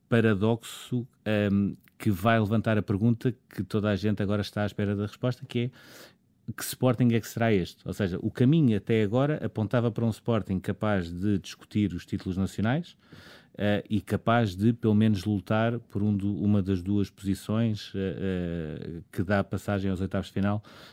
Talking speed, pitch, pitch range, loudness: 185 wpm, 105 Hz, 100-115 Hz, -28 LUFS